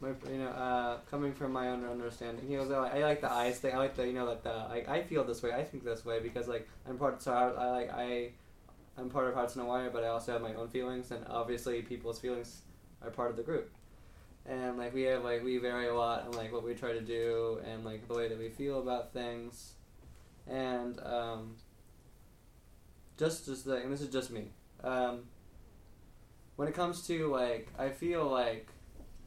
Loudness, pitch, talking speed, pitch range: -37 LUFS, 120 Hz, 225 wpm, 115-130 Hz